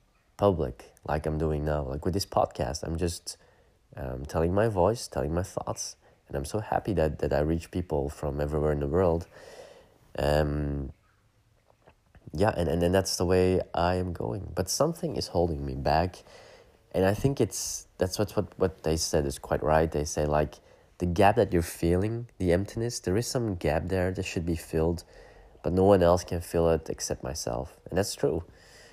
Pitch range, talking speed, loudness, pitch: 75-95 Hz, 195 wpm, -28 LUFS, 85 Hz